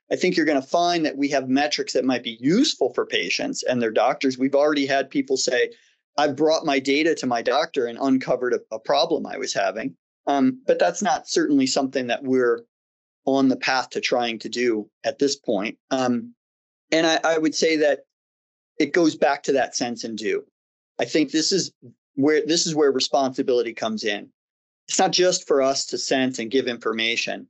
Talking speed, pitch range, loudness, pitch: 205 wpm, 125-175 Hz, -22 LUFS, 140 Hz